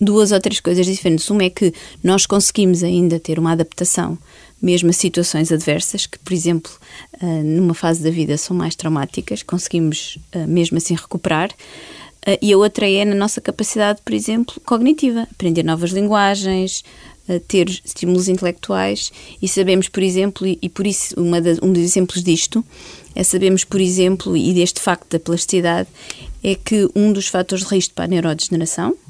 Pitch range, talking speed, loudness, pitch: 170-195 Hz, 165 wpm, -17 LUFS, 180 Hz